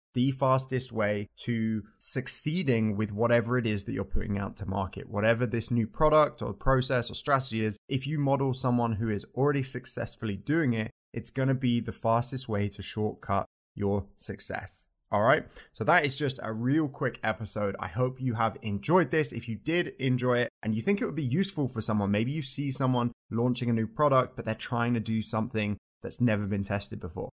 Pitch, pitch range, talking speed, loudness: 120 Hz, 110-130 Hz, 205 wpm, -29 LUFS